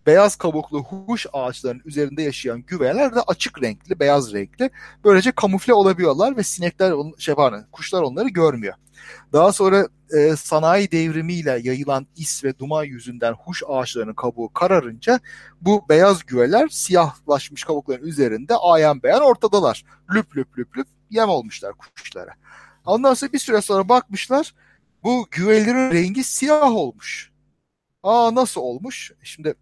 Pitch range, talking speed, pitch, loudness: 140-215 Hz, 135 wpm, 170 Hz, -19 LUFS